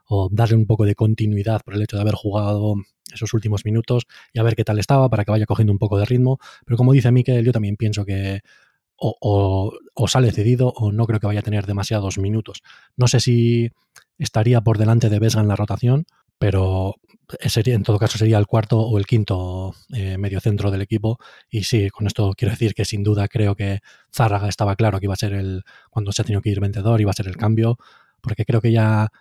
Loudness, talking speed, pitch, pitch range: -20 LUFS, 235 wpm, 110 Hz, 100-115 Hz